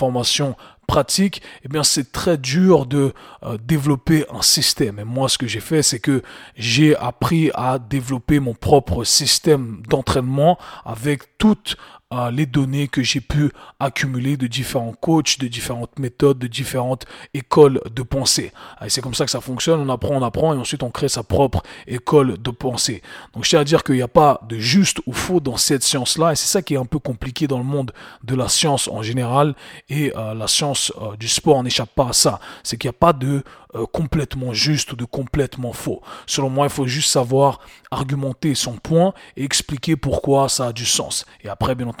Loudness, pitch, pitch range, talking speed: -18 LUFS, 135 Hz, 125-150 Hz, 205 wpm